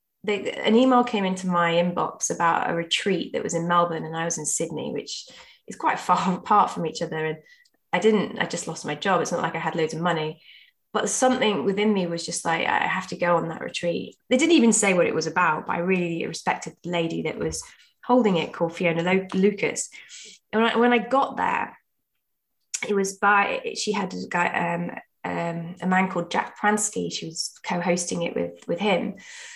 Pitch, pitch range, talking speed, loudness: 180 Hz, 170-210 Hz, 220 wpm, -24 LUFS